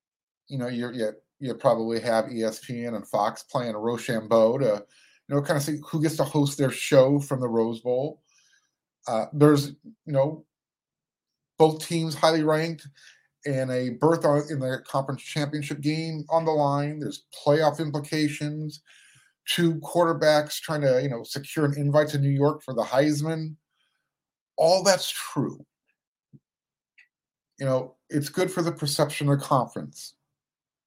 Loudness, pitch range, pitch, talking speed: -25 LUFS, 130-155 Hz, 145 Hz, 150 wpm